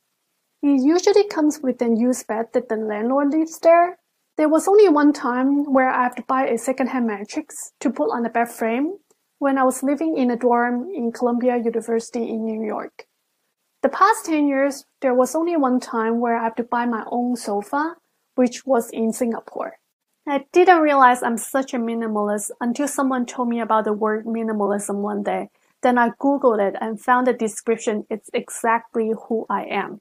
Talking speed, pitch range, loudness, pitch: 190 wpm, 225-280 Hz, -20 LUFS, 245 Hz